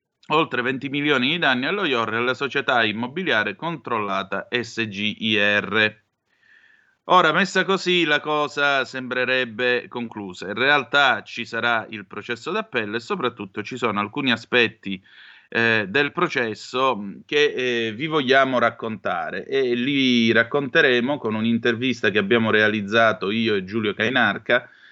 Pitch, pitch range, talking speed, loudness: 120 Hz, 110-140 Hz, 125 wpm, -21 LUFS